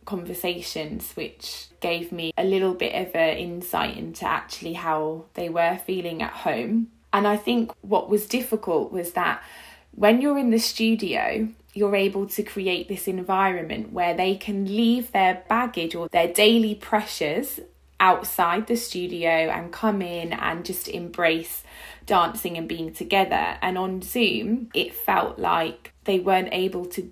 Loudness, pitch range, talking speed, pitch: -24 LUFS, 175-215 Hz, 155 wpm, 190 Hz